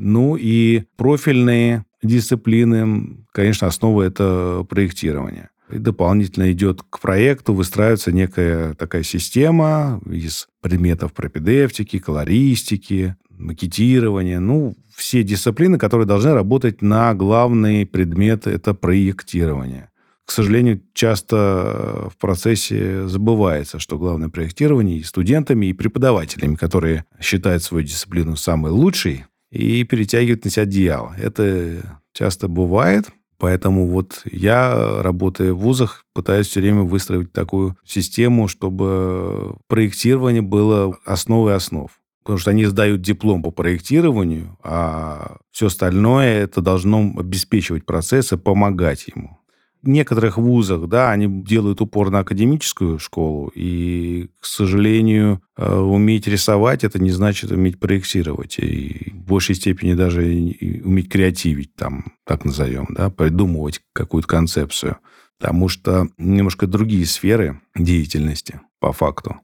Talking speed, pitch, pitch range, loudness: 115 wpm, 100 Hz, 90-110 Hz, -18 LUFS